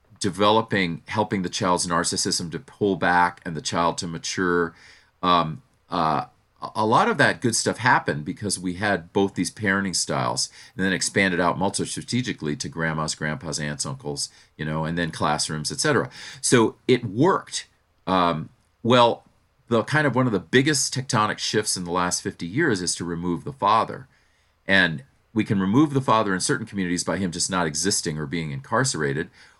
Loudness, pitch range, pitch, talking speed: -23 LUFS, 85-105 Hz, 90 Hz, 175 wpm